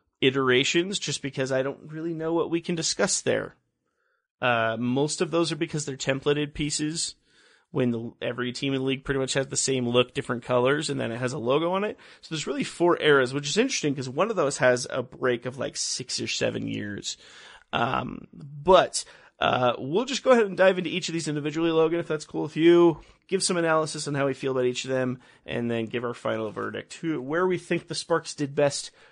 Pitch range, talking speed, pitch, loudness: 130-165 Hz, 225 wpm, 145 Hz, -26 LUFS